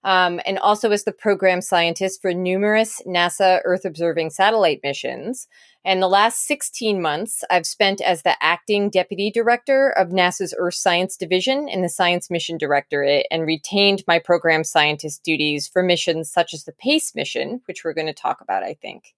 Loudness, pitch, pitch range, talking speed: -19 LUFS, 185 Hz, 170-200 Hz, 180 wpm